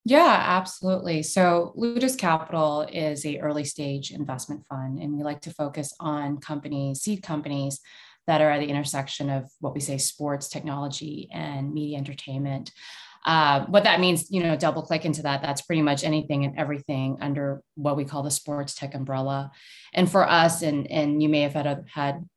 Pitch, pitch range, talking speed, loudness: 150 Hz, 140-160 Hz, 180 wpm, -25 LUFS